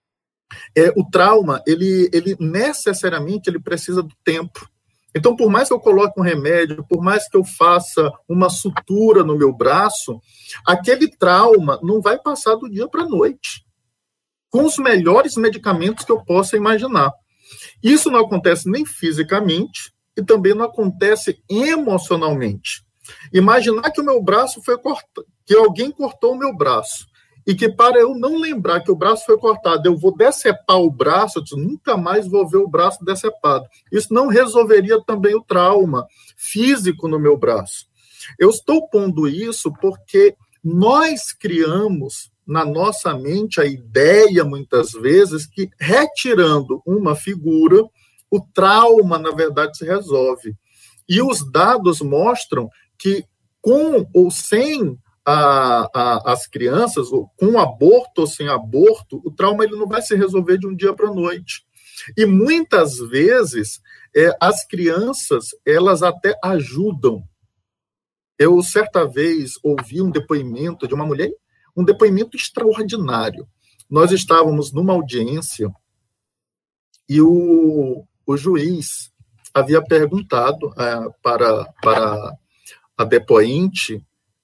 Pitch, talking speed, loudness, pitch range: 190 Hz, 135 wpm, -16 LUFS, 150-225 Hz